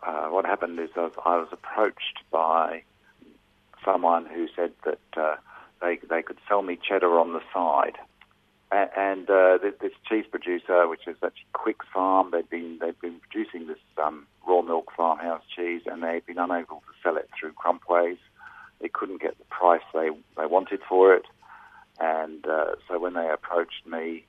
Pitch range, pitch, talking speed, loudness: 80-95 Hz, 85 Hz, 185 wpm, -26 LUFS